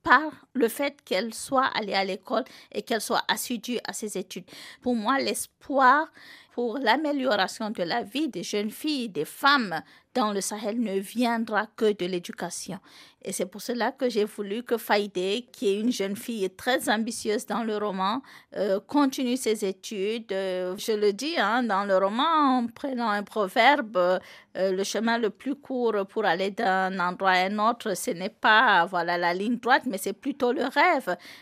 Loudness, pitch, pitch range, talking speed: -26 LUFS, 220 Hz, 195-250 Hz, 180 wpm